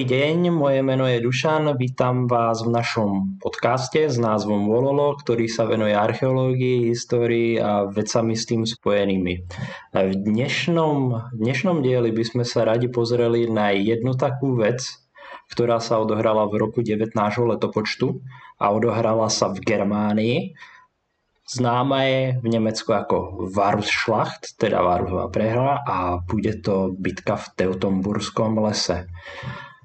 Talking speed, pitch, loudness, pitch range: 130 wpm, 115 Hz, -21 LUFS, 105-125 Hz